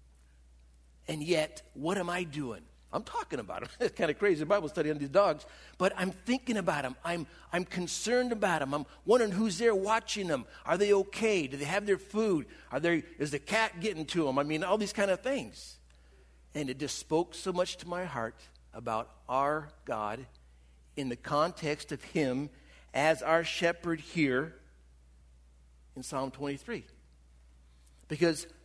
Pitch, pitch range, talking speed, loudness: 155 Hz, 115-185 Hz, 175 wpm, -32 LUFS